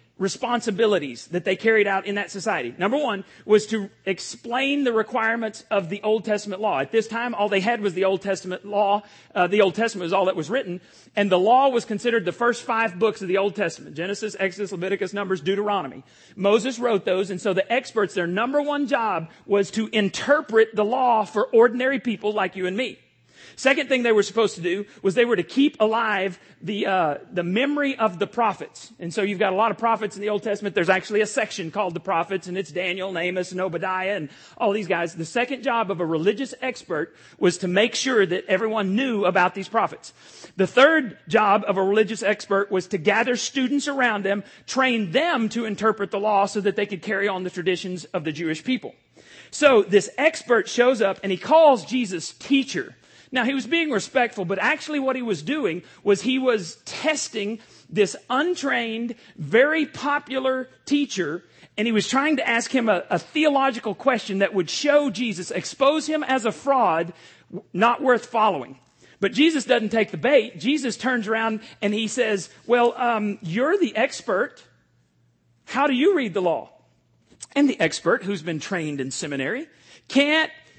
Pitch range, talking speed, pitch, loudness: 190-245 Hz, 195 wpm, 210 Hz, -22 LUFS